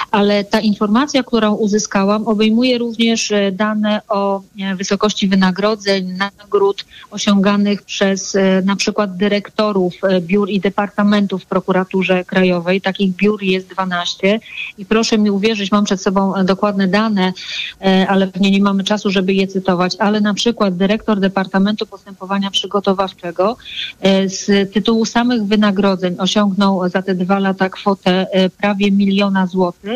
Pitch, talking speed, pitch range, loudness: 200 Hz, 130 wpm, 190-210 Hz, -15 LUFS